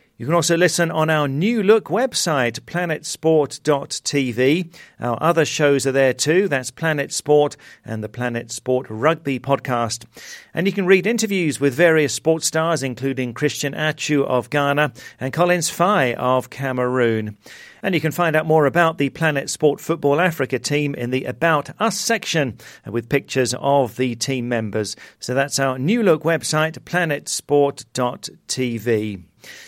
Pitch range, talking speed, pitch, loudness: 125-165 Hz, 150 wpm, 145 Hz, -20 LUFS